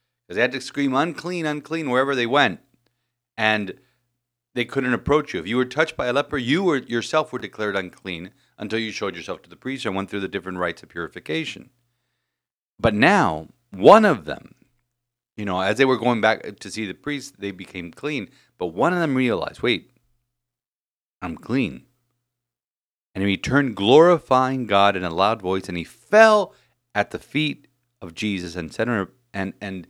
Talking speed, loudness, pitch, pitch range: 185 wpm, -21 LUFS, 120 Hz, 95-130 Hz